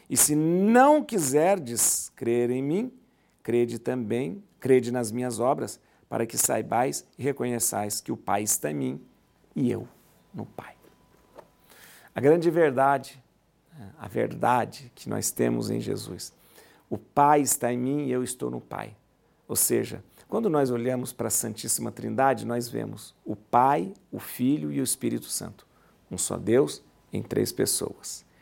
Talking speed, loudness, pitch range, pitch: 155 wpm, -26 LUFS, 120-150 Hz, 125 Hz